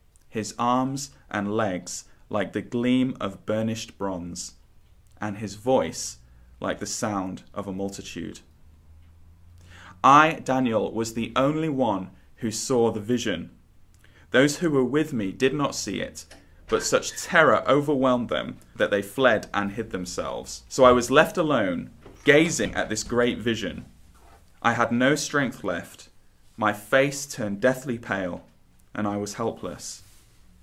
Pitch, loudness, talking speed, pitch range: 110 Hz, -24 LUFS, 145 wpm, 90-130 Hz